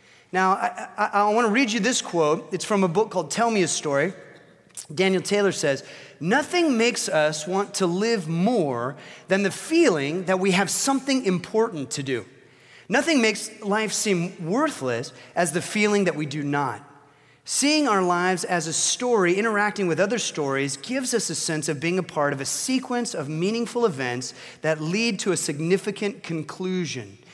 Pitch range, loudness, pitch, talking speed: 155-220 Hz, -23 LUFS, 185 Hz, 180 wpm